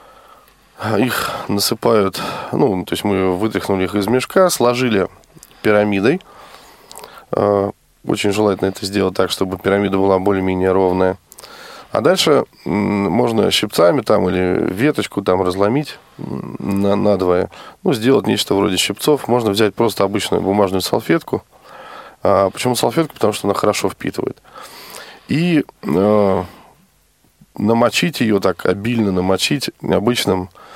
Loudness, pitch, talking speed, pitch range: -17 LUFS, 100 Hz, 115 wpm, 95-105 Hz